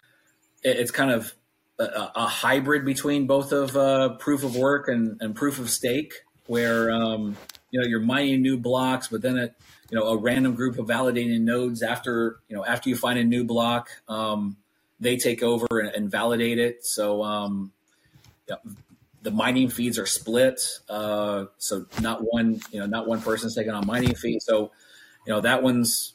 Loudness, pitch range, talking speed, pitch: -25 LUFS, 110-130 Hz, 185 wpm, 120 Hz